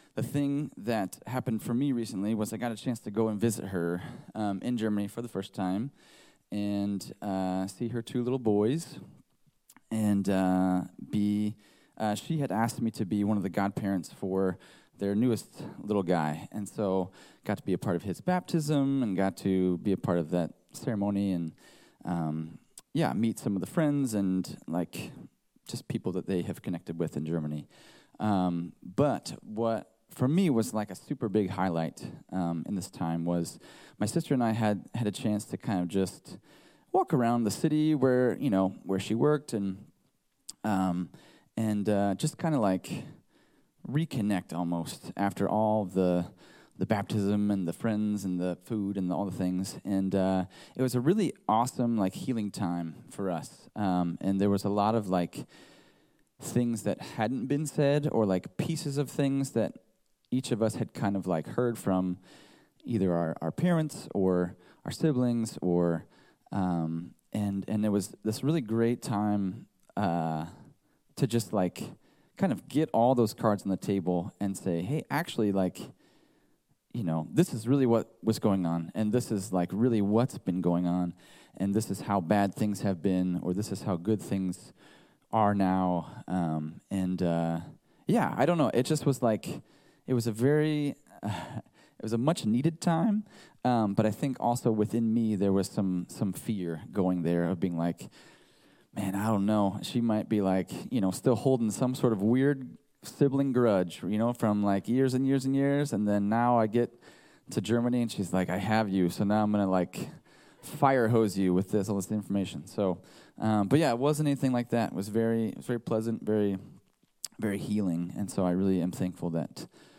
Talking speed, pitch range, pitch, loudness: 190 wpm, 95-120 Hz, 105 Hz, -30 LUFS